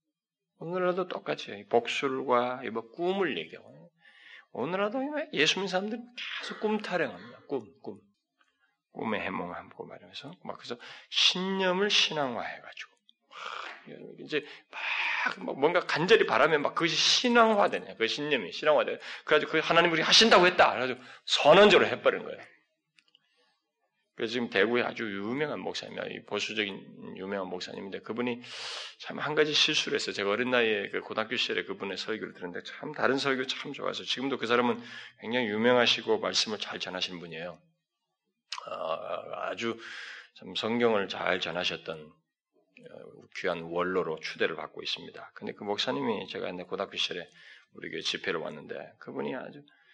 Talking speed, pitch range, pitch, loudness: 340 characters per minute, 110-190 Hz, 140 Hz, -28 LUFS